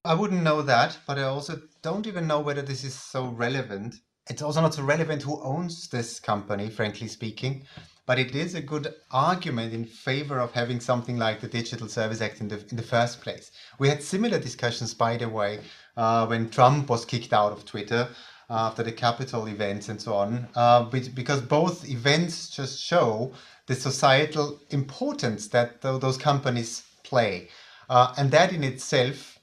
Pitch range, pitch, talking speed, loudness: 115-145 Hz, 125 Hz, 185 wpm, -26 LUFS